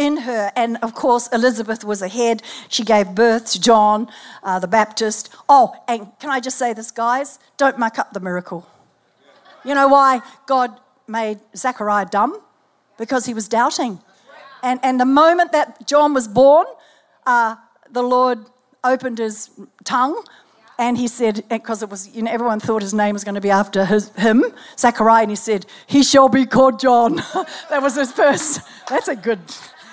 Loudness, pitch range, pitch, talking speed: -17 LUFS, 220-265 Hz, 235 Hz, 180 wpm